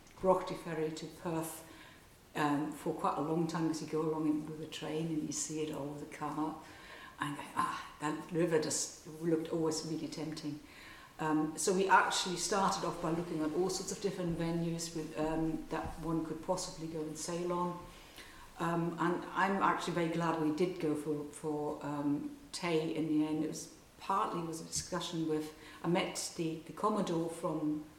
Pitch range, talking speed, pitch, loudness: 155-170 Hz, 190 wpm, 160 Hz, -36 LUFS